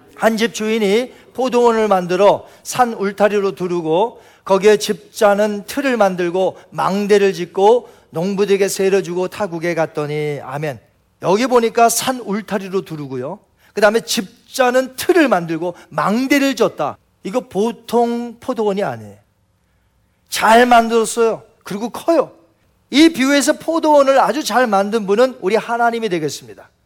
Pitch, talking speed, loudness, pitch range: 210 Hz, 300 characters per minute, -16 LUFS, 180-235 Hz